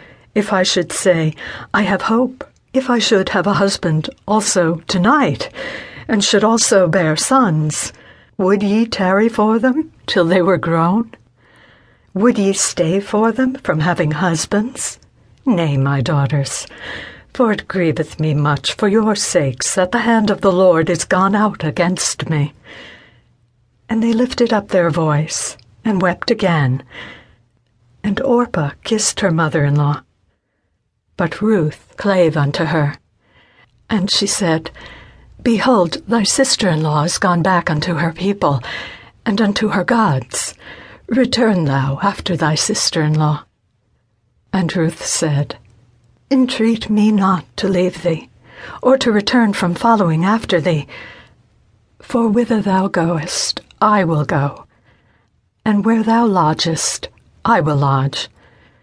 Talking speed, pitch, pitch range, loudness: 135 wpm, 185 Hz, 155-215 Hz, -16 LUFS